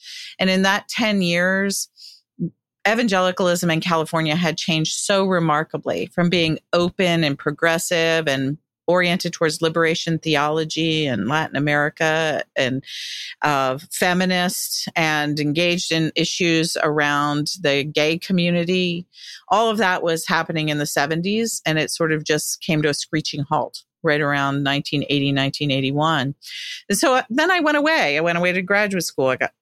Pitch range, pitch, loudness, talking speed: 150-180 Hz, 160 Hz, -20 LUFS, 150 wpm